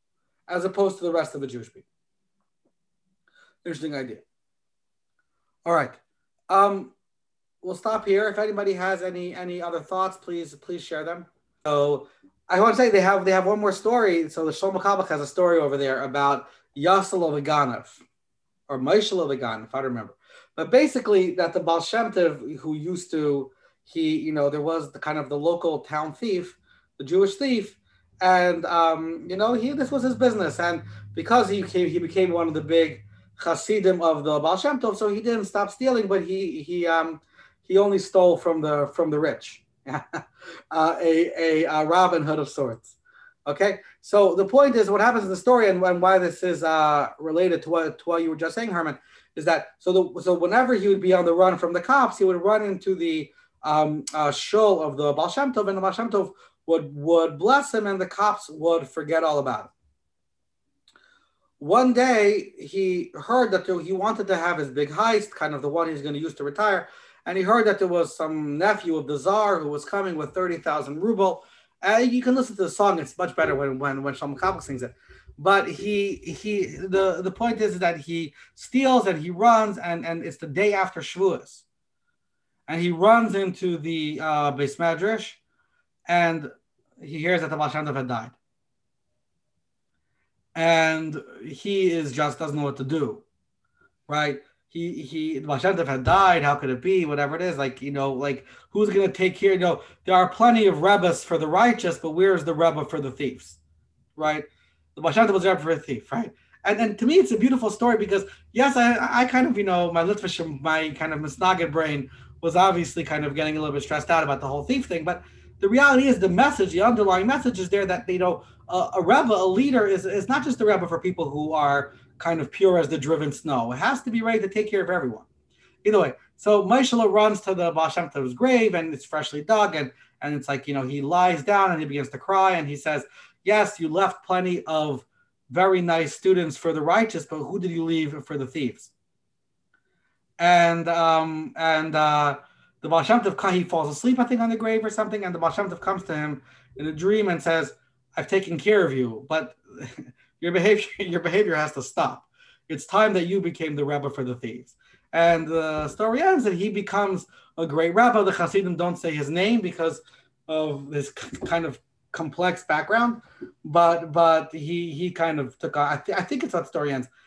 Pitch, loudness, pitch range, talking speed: 175 Hz, -23 LUFS, 155-200 Hz, 205 wpm